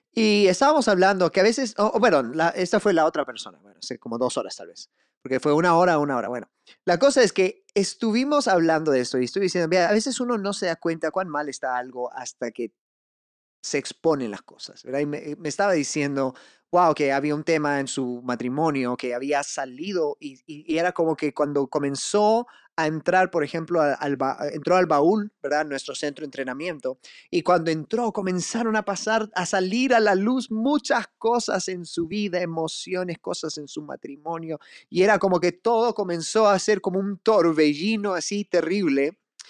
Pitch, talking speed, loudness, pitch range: 175 Hz, 200 wpm, -23 LUFS, 150-205 Hz